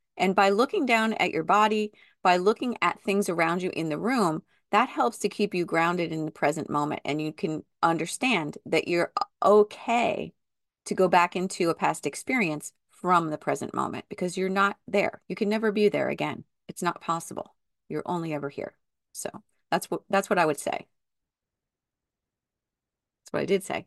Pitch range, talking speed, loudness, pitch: 165-210 Hz, 185 wpm, -26 LUFS, 185 Hz